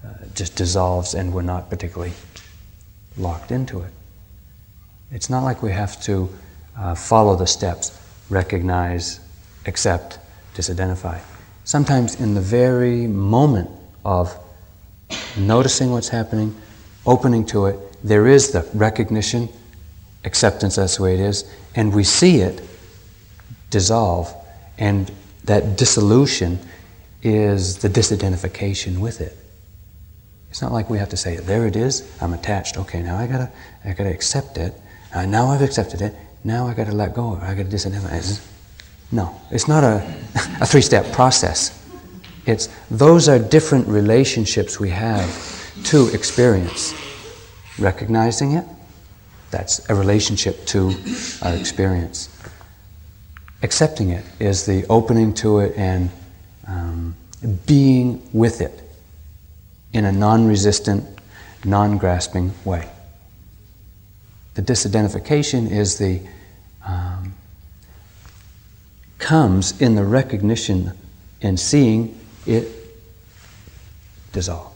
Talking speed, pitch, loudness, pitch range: 115 wpm, 100 Hz, -18 LUFS, 90-110 Hz